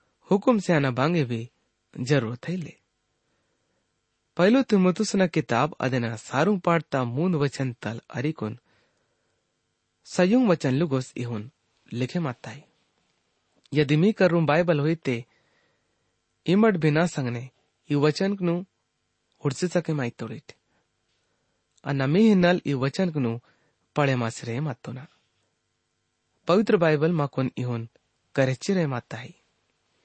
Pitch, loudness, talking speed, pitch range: 145 Hz, -24 LUFS, 115 wpm, 120-170 Hz